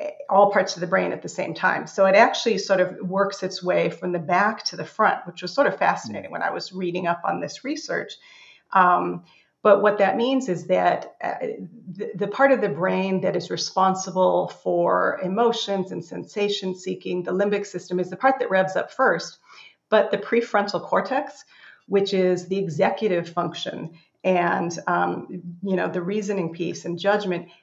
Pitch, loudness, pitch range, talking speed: 190 Hz, -23 LUFS, 180-205 Hz, 185 wpm